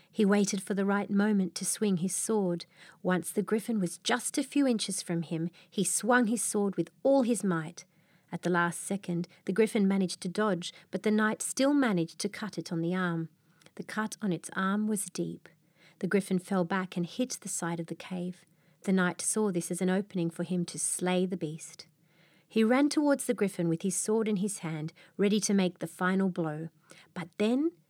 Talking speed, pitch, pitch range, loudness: 210 wpm, 185 Hz, 170-210 Hz, -30 LUFS